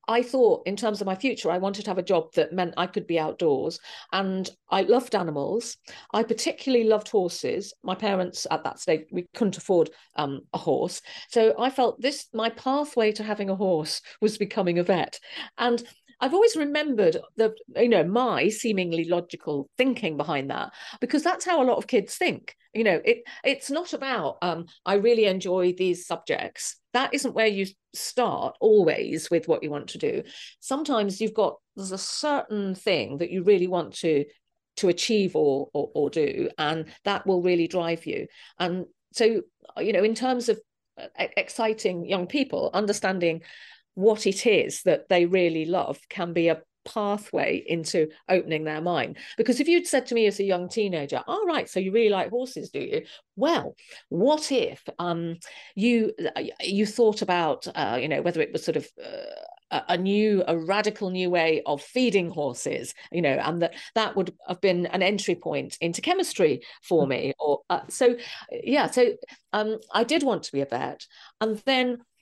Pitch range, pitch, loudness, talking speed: 180-255 Hz, 205 Hz, -25 LUFS, 185 wpm